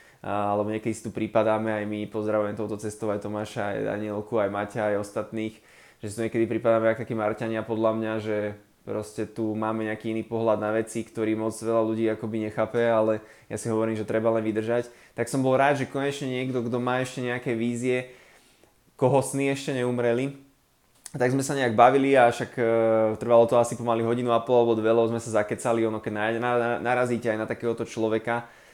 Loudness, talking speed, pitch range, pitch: -26 LUFS, 195 wpm, 110-120 Hz, 115 Hz